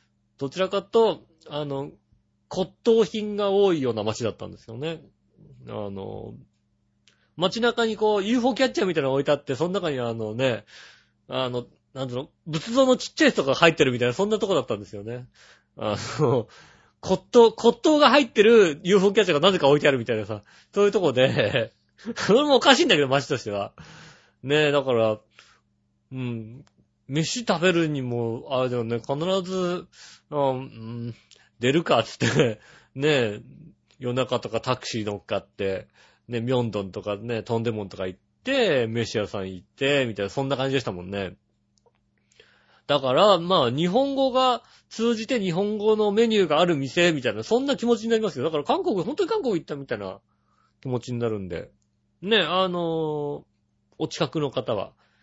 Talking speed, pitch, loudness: 340 characters per minute, 140 Hz, -23 LUFS